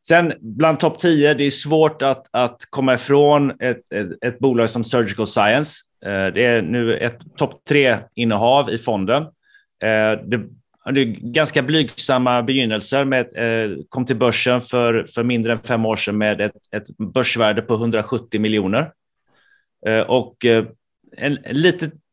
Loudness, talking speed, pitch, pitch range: -18 LUFS, 145 wpm, 120 Hz, 110-140 Hz